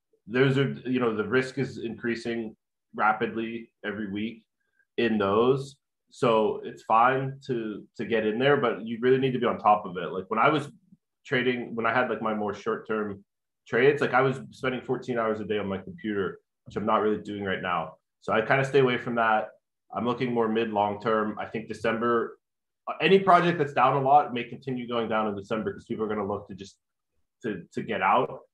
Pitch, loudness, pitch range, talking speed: 115 Hz, -26 LUFS, 105-130 Hz, 220 wpm